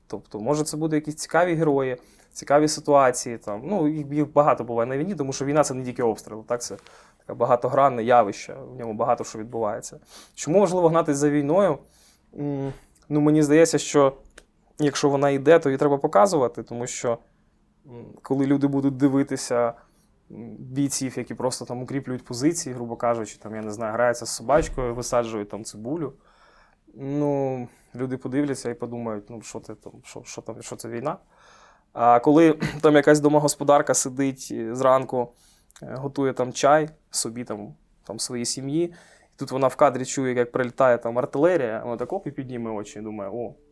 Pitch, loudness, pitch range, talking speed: 130 Hz, -23 LUFS, 120-145 Hz, 165 wpm